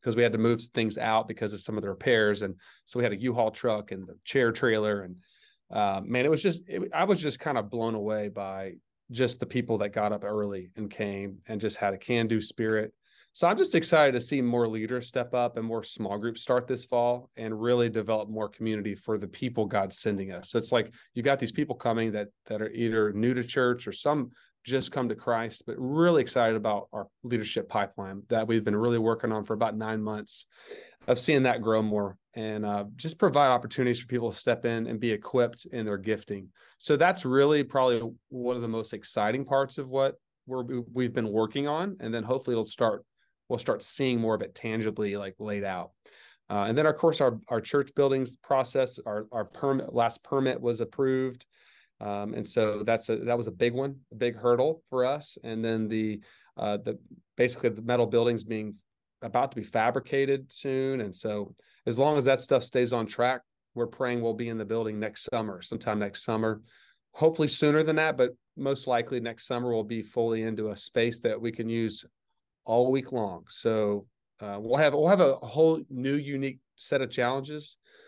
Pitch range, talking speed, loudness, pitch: 110-130 Hz, 215 wpm, -29 LUFS, 115 Hz